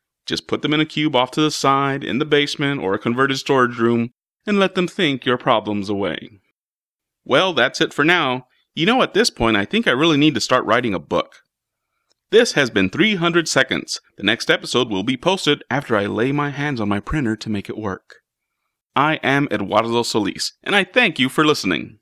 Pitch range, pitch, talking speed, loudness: 115-155 Hz, 140 Hz, 215 wpm, -18 LUFS